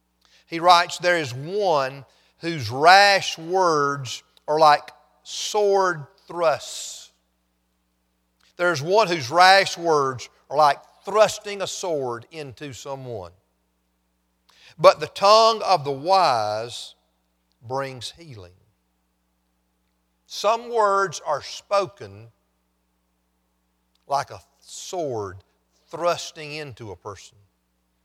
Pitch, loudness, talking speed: 130 Hz, -20 LUFS, 95 wpm